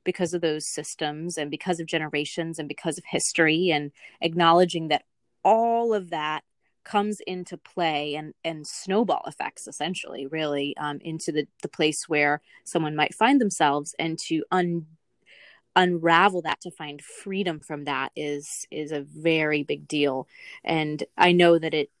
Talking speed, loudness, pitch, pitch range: 160 wpm, -25 LUFS, 160 Hz, 150-175 Hz